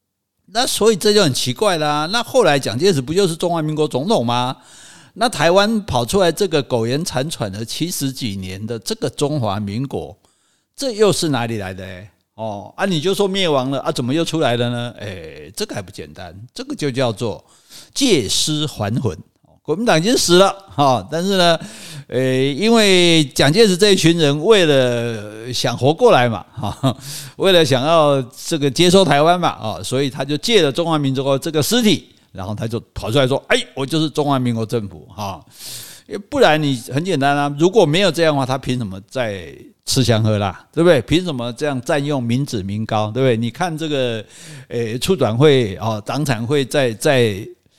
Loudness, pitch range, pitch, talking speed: -17 LUFS, 120-165 Hz, 135 Hz, 275 characters per minute